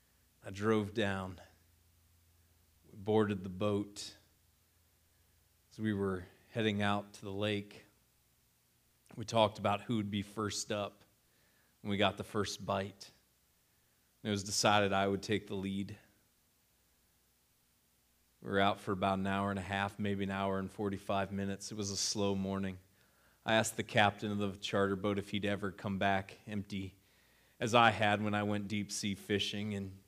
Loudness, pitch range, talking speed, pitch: -35 LUFS, 90-105 Hz, 165 wpm, 100 Hz